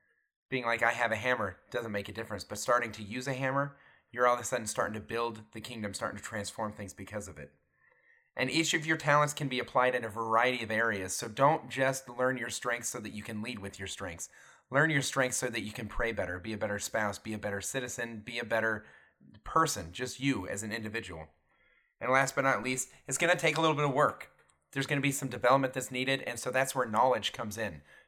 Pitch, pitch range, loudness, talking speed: 120 Hz, 105-135 Hz, -32 LUFS, 245 wpm